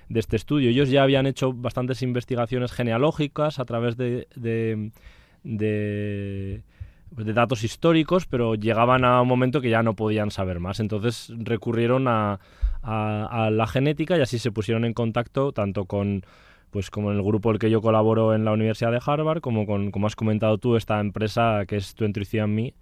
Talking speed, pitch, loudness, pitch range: 185 wpm, 115 Hz, -24 LUFS, 105-125 Hz